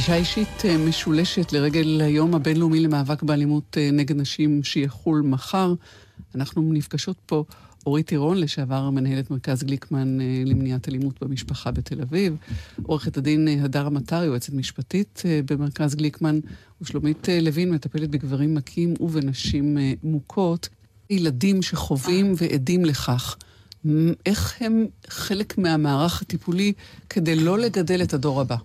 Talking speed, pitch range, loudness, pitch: 115 wpm, 140-170 Hz, -23 LUFS, 150 Hz